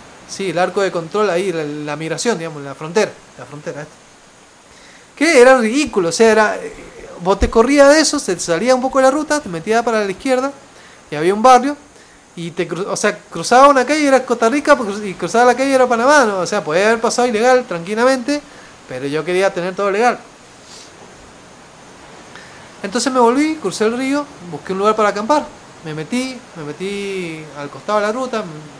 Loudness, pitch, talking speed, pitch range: -15 LUFS, 215 Hz, 195 wpm, 180-255 Hz